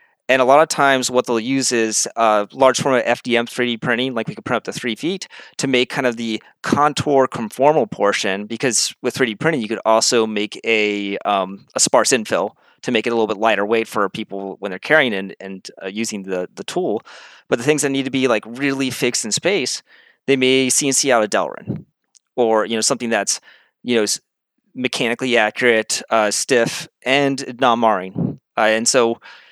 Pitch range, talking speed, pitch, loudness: 110-135 Hz, 205 wpm, 120 Hz, -18 LUFS